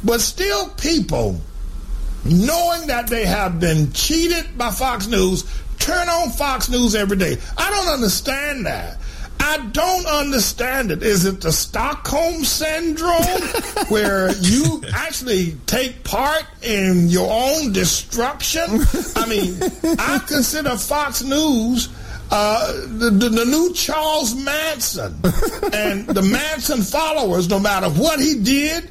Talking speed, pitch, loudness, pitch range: 130 wpm, 255 Hz, -18 LUFS, 205-310 Hz